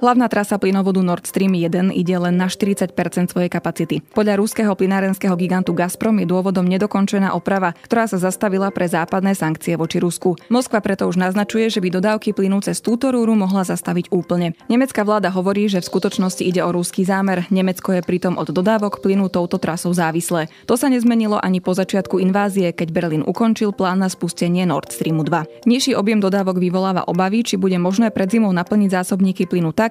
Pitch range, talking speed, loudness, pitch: 180-205 Hz, 185 wpm, -18 LUFS, 190 Hz